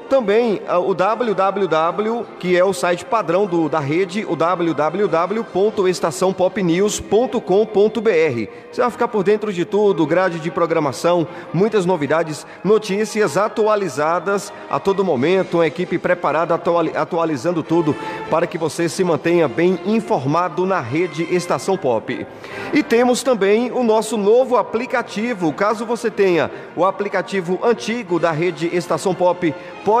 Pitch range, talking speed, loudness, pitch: 170-215 Hz, 130 wpm, -18 LUFS, 185 Hz